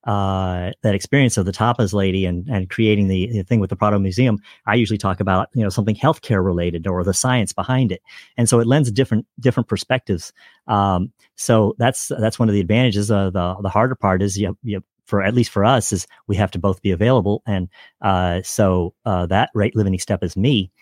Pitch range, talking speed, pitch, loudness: 95-115 Hz, 215 wpm, 100 Hz, -19 LUFS